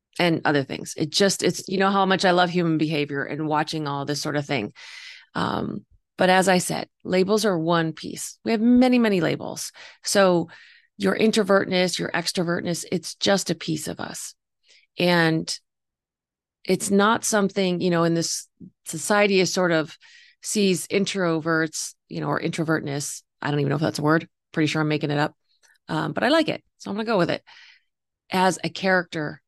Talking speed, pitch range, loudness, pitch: 190 wpm, 160-195 Hz, -23 LUFS, 180 Hz